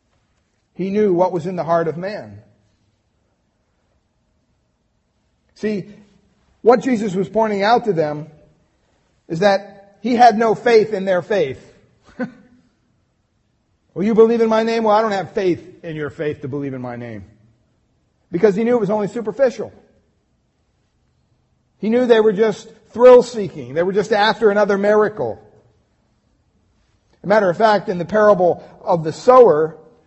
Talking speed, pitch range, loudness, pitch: 150 wpm, 150-220 Hz, -16 LUFS, 200 Hz